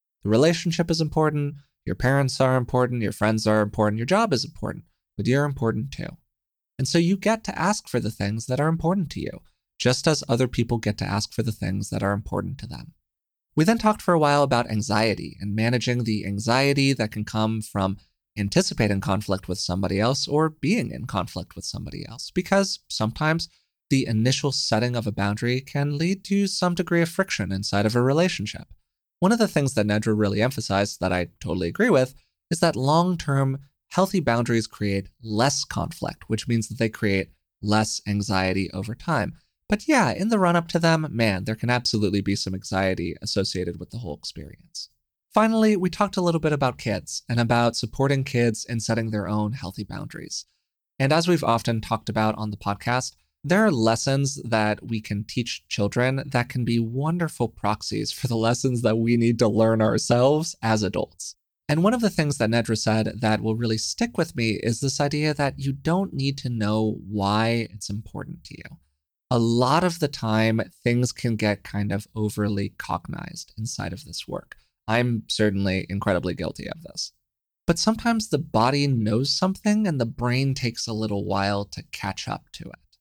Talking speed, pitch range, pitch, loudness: 190 wpm, 105-145 Hz, 115 Hz, -24 LUFS